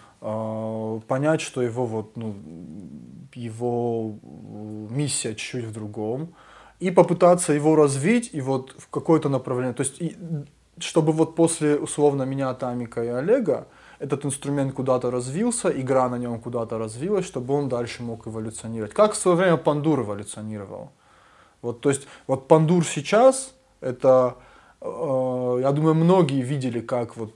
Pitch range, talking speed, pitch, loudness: 120-155 Hz, 140 wpm, 135 Hz, -23 LUFS